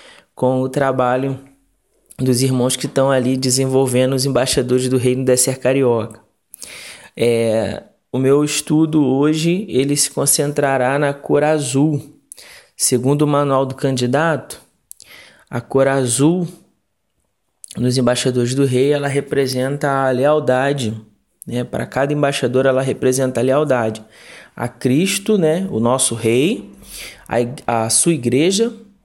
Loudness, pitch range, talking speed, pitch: -17 LUFS, 125-145 Hz, 125 wpm, 135 Hz